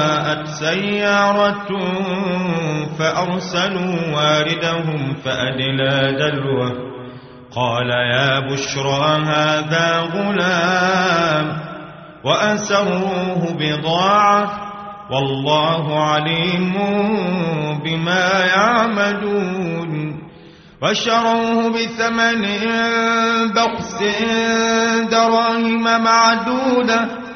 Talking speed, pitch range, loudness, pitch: 45 wpm, 150-210 Hz, -17 LUFS, 180 Hz